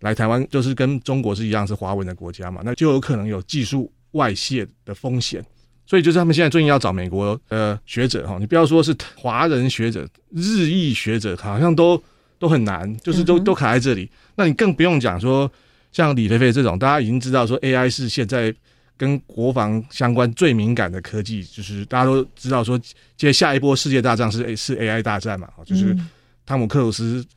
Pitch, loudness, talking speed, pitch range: 125 Hz, -19 LUFS, 310 characters per minute, 110-140 Hz